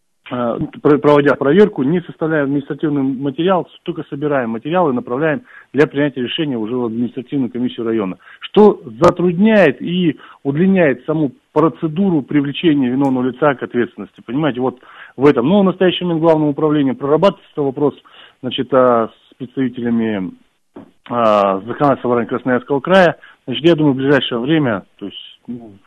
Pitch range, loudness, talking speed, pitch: 125-160 Hz, -16 LUFS, 135 wpm, 145 Hz